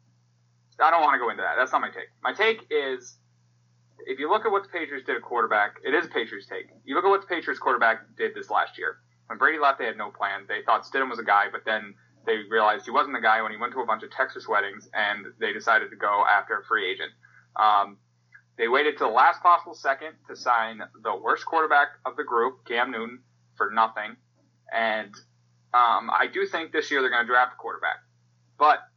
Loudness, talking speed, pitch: -25 LUFS, 235 wpm, 115 Hz